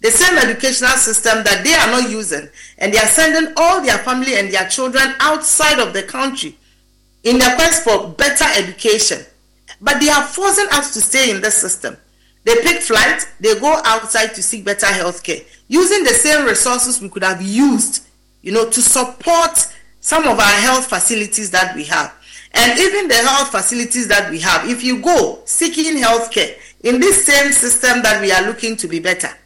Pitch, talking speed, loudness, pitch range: 250 Hz, 195 wpm, -13 LUFS, 220-310 Hz